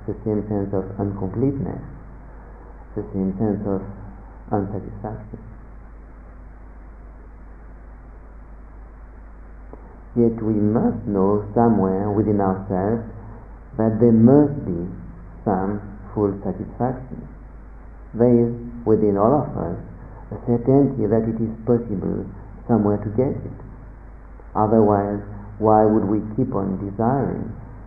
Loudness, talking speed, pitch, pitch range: -21 LUFS, 100 wpm, 105 Hz, 95-115 Hz